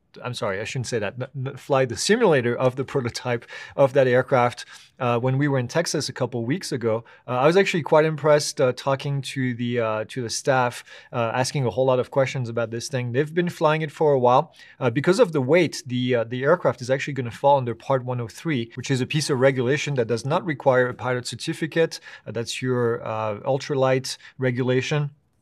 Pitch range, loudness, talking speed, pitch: 125-145 Hz, -23 LUFS, 215 wpm, 130 Hz